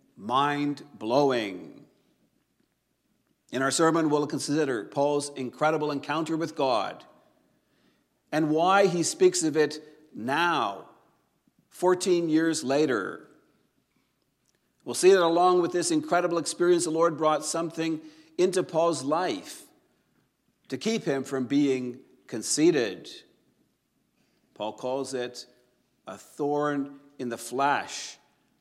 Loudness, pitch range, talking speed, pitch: -26 LUFS, 145-170 Hz, 105 wpm, 155 Hz